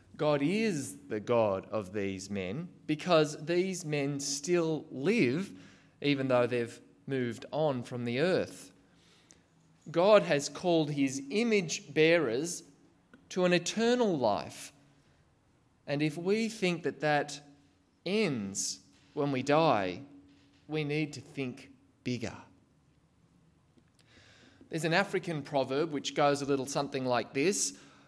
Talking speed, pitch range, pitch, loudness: 120 wpm, 125-165 Hz, 145 Hz, -31 LUFS